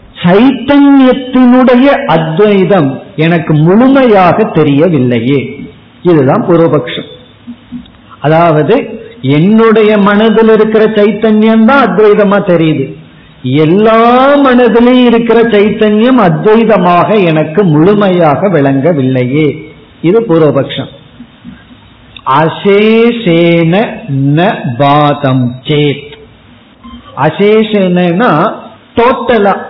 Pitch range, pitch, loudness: 150-225 Hz, 195 Hz, -7 LUFS